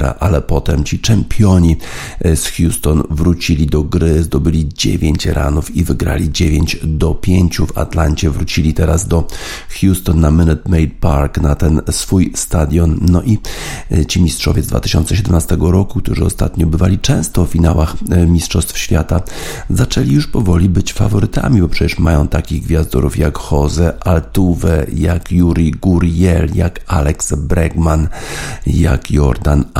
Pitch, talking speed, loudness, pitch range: 85 Hz, 135 wpm, -14 LUFS, 80-90 Hz